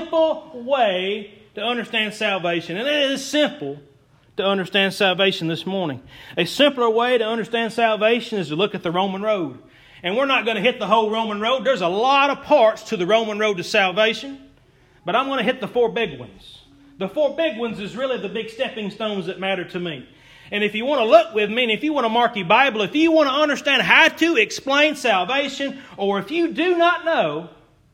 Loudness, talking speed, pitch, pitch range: -20 LUFS, 215 wpm, 225 Hz, 195-275 Hz